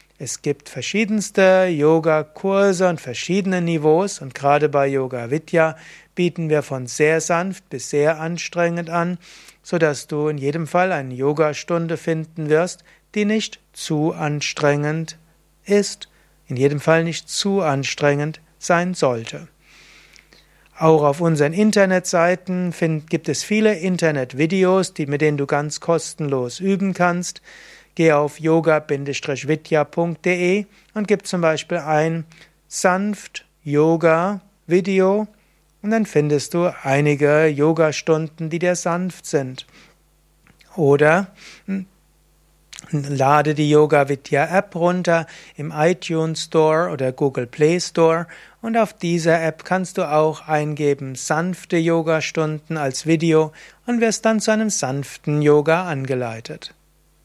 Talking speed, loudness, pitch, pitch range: 110 wpm, -19 LUFS, 160 Hz, 150-180 Hz